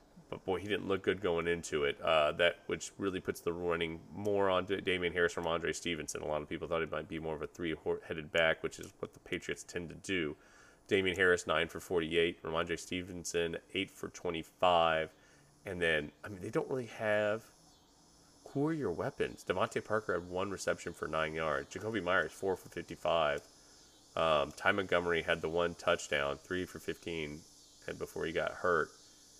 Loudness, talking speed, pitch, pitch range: -35 LUFS, 195 wpm, 85 Hz, 80-105 Hz